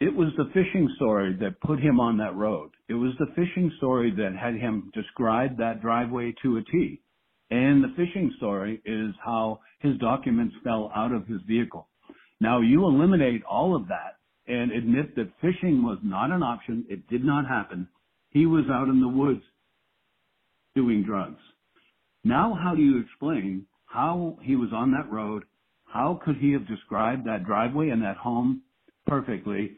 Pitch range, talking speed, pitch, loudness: 110-150 Hz, 175 wpm, 125 Hz, -26 LUFS